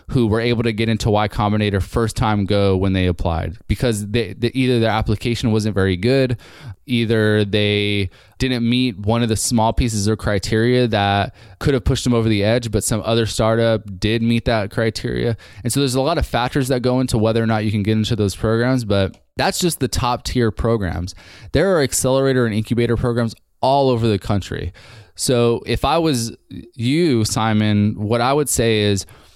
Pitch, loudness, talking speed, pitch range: 115 Hz, -18 LUFS, 200 wpm, 105-120 Hz